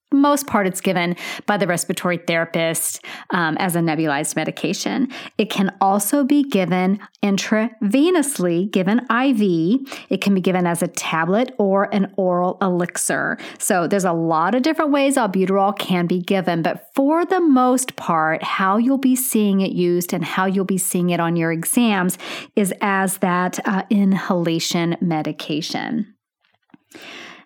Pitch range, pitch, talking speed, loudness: 175-225 Hz, 195 Hz, 150 wpm, -19 LUFS